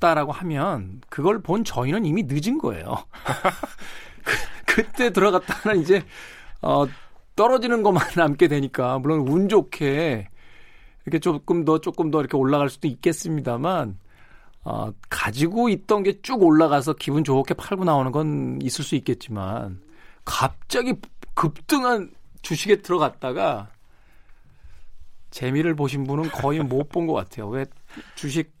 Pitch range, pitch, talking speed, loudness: 135-180 Hz, 155 Hz, 270 characters per minute, -23 LUFS